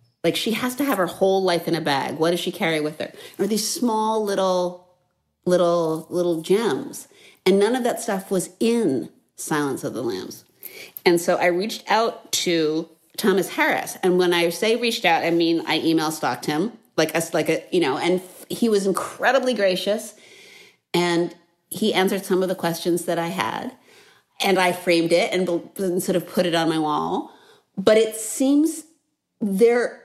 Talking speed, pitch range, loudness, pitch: 185 wpm, 170-220 Hz, -22 LUFS, 180 Hz